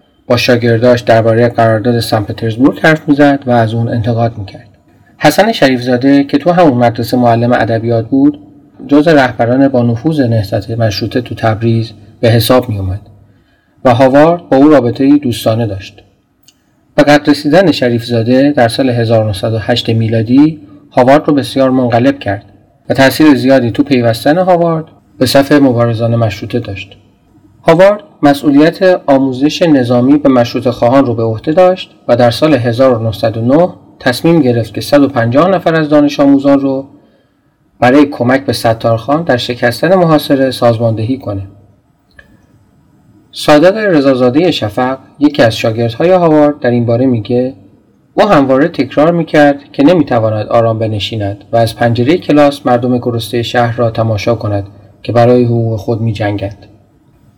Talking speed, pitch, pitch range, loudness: 135 wpm, 125 Hz, 115-145 Hz, -10 LUFS